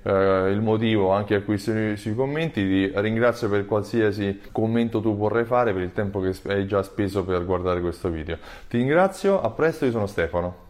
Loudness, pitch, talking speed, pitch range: -23 LUFS, 105 Hz, 185 wpm, 95-115 Hz